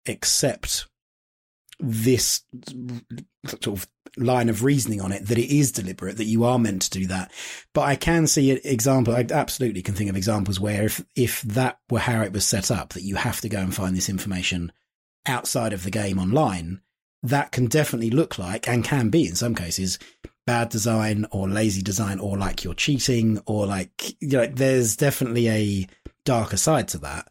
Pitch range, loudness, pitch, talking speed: 95-125 Hz, -23 LUFS, 110 Hz, 190 wpm